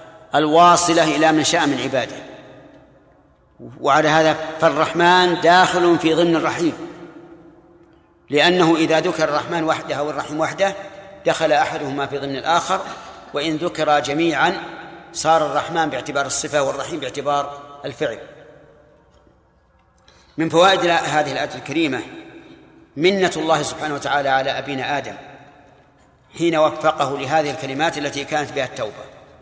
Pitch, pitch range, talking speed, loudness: 155 Hz, 145-170 Hz, 110 wpm, -18 LUFS